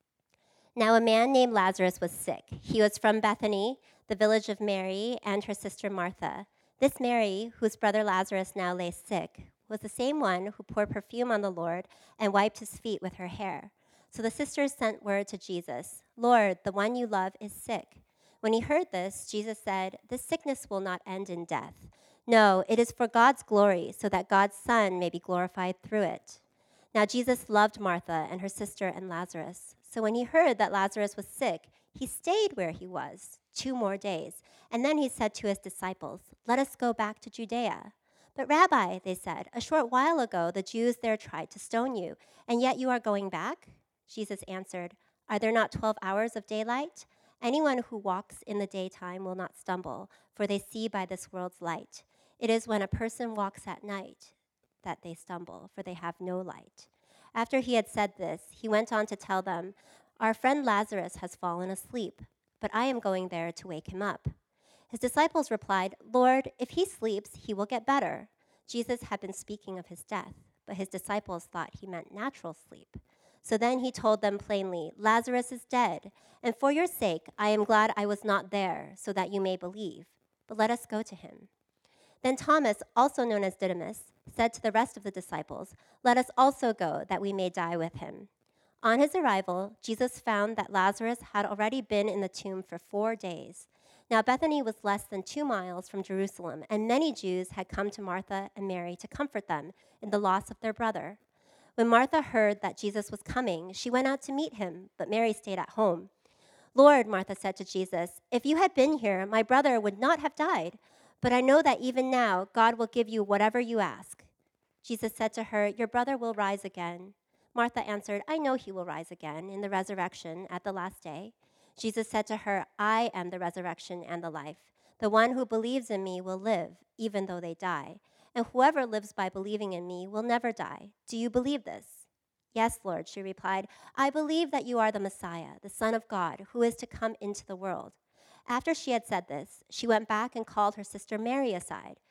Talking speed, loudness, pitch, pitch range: 200 wpm, -30 LUFS, 210 Hz, 190-235 Hz